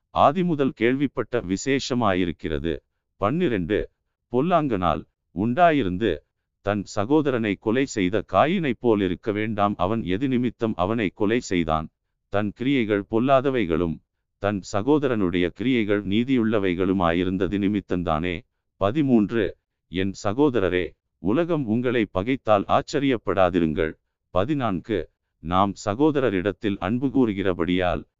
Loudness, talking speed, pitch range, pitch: -23 LUFS, 85 wpm, 95-125 Hz, 100 Hz